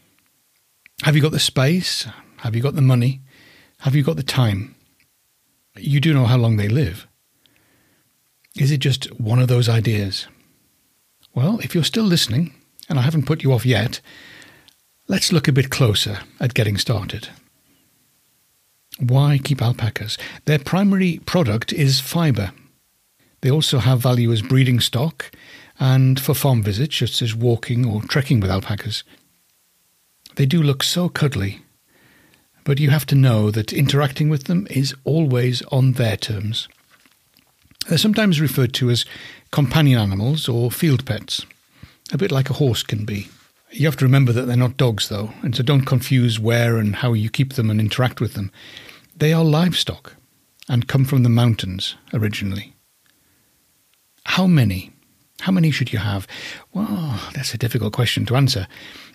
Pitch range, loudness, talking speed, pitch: 115-145 Hz, -19 LUFS, 160 wpm, 130 Hz